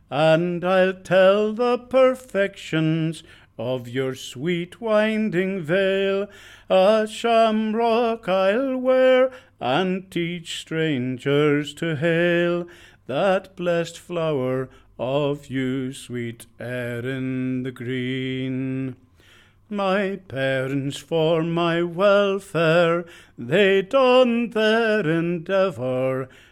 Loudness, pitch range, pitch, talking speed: -22 LUFS, 130-195 Hz, 170 Hz, 85 wpm